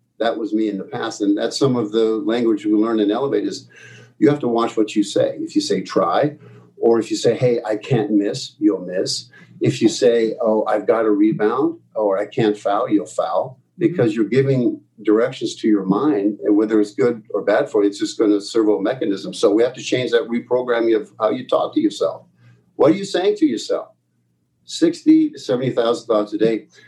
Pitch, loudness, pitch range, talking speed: 115 Hz, -19 LUFS, 105-155 Hz, 220 wpm